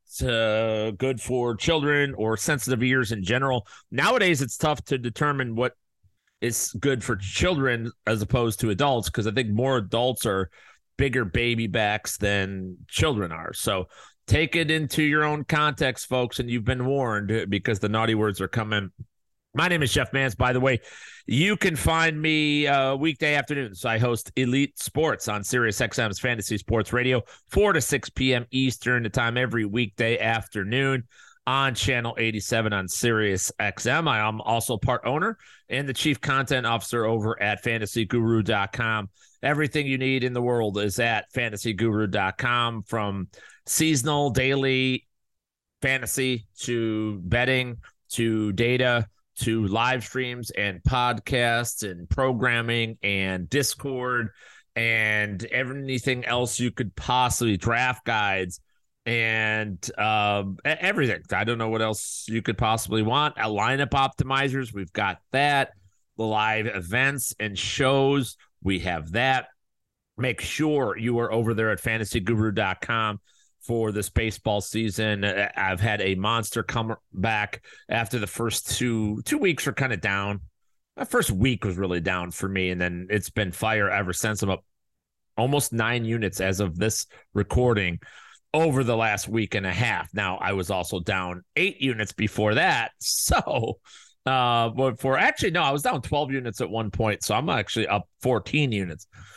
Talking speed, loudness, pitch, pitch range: 155 wpm, -25 LUFS, 115 Hz, 105-130 Hz